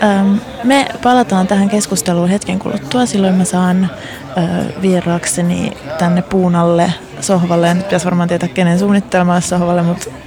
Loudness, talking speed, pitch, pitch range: -14 LUFS, 125 wpm, 180 Hz, 175-200 Hz